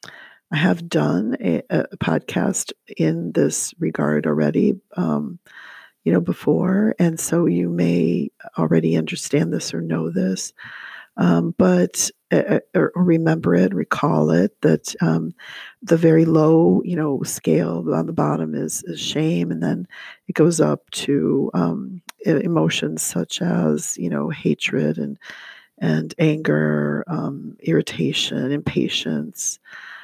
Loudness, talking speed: -20 LUFS, 130 wpm